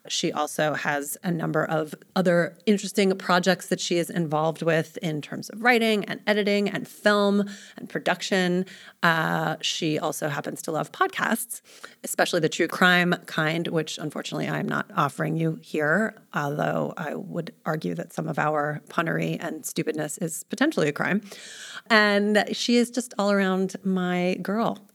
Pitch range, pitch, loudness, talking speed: 160-210 Hz, 185 Hz, -25 LUFS, 160 wpm